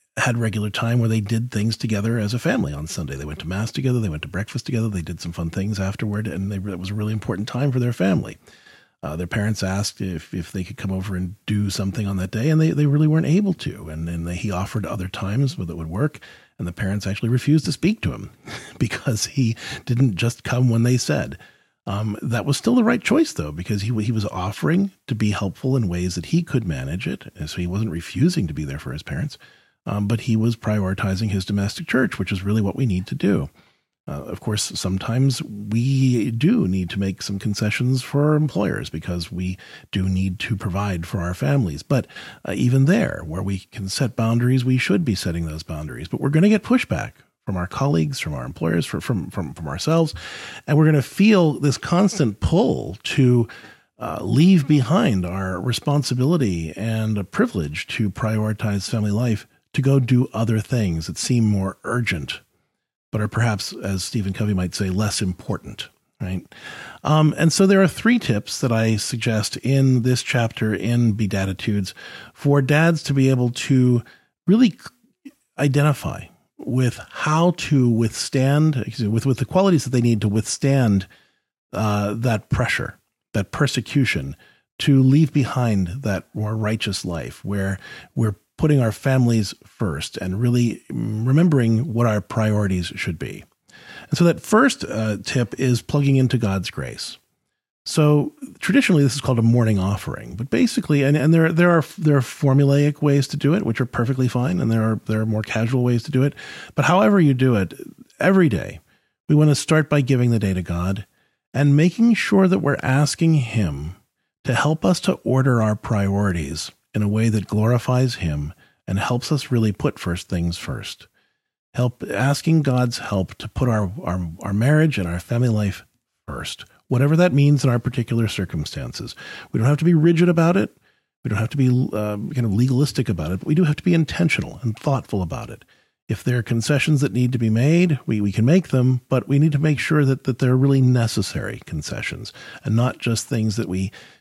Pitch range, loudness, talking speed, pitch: 100-140 Hz, -21 LUFS, 200 wpm, 115 Hz